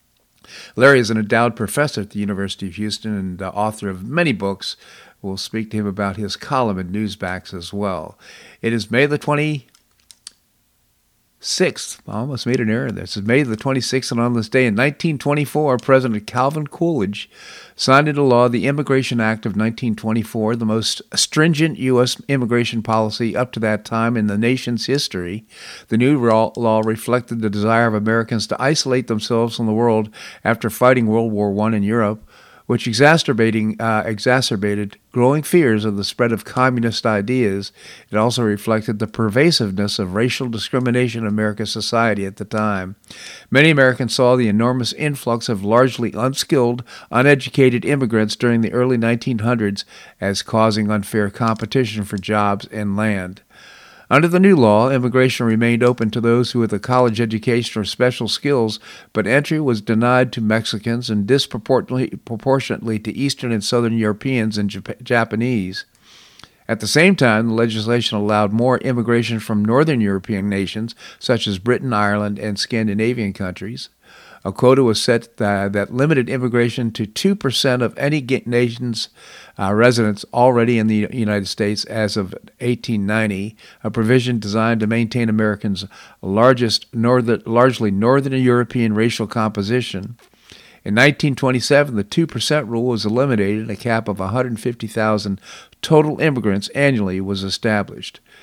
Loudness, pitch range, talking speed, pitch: -18 LUFS, 105-125 Hz, 155 wpm, 115 Hz